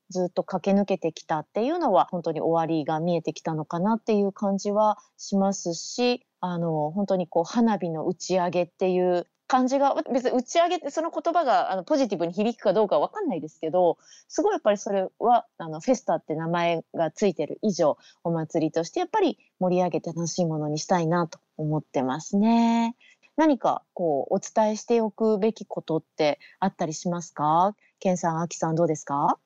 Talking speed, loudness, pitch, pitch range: 400 characters per minute, -25 LUFS, 185 Hz, 165-230 Hz